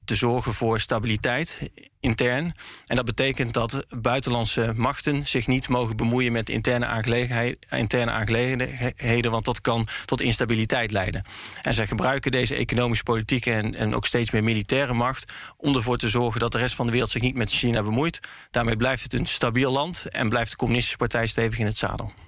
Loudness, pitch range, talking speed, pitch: -24 LUFS, 115-125 Hz, 185 wpm, 120 Hz